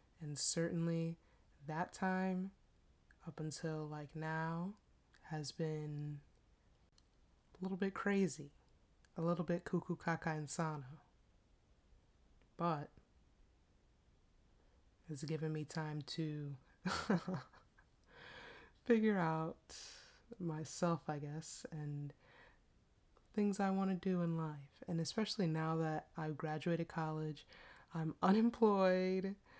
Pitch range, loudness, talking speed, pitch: 150-185 Hz, -40 LUFS, 95 wpm, 160 Hz